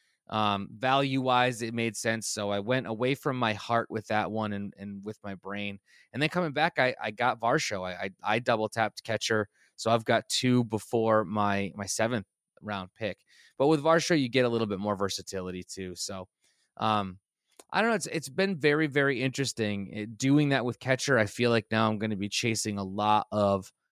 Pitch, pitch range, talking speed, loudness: 110 Hz, 100-130 Hz, 205 wpm, -29 LUFS